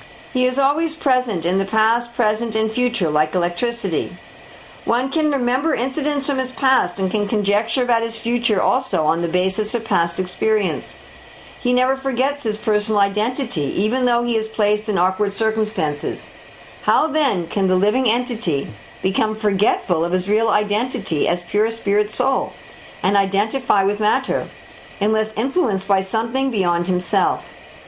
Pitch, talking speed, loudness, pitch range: 220 Hz, 155 wpm, -20 LUFS, 195-250 Hz